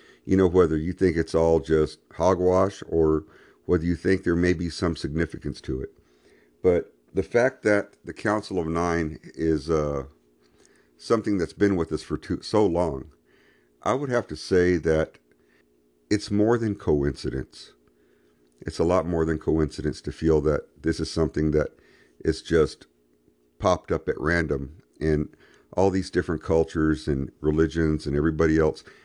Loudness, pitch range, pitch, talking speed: -25 LUFS, 75-90 Hz, 80 Hz, 160 wpm